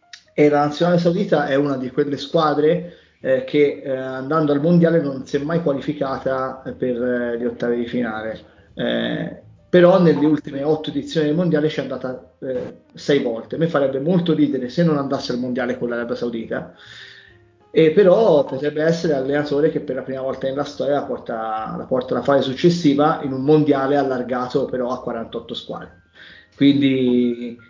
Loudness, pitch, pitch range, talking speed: -19 LUFS, 140 Hz, 130-155 Hz, 170 wpm